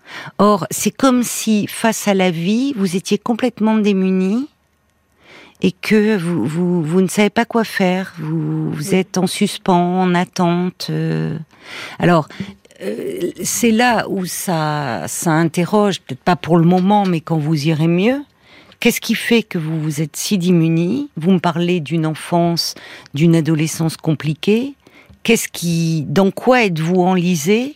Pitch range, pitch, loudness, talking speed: 165-210 Hz, 185 Hz, -17 LUFS, 150 wpm